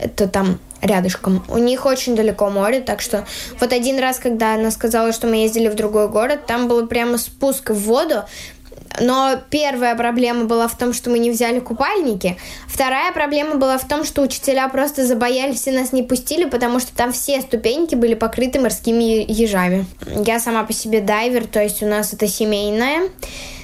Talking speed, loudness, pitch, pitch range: 185 wpm, -18 LUFS, 235 Hz, 220-260 Hz